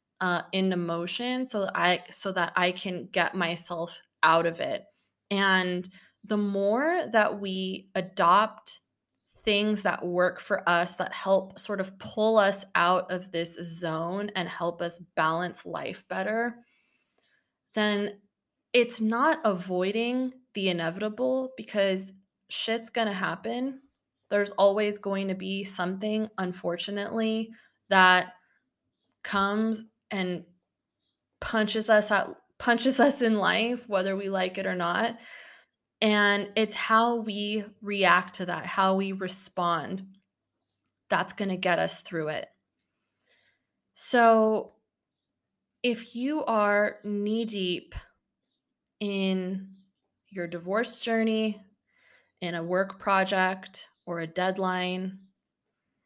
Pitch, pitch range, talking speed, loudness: 195 Hz, 180-220 Hz, 115 wpm, -27 LUFS